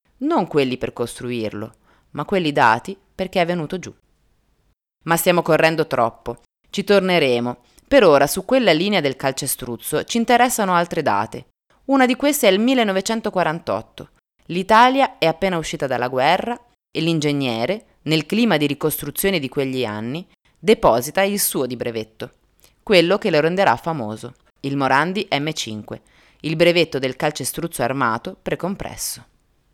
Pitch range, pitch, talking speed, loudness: 130-195 Hz, 160 Hz, 135 wpm, -19 LUFS